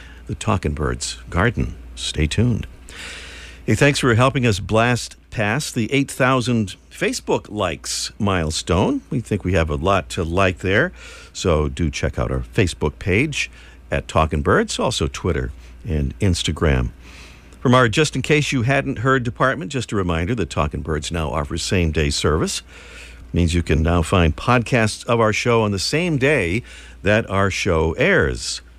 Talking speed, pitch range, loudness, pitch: 165 wpm, 75-115 Hz, -20 LUFS, 90 Hz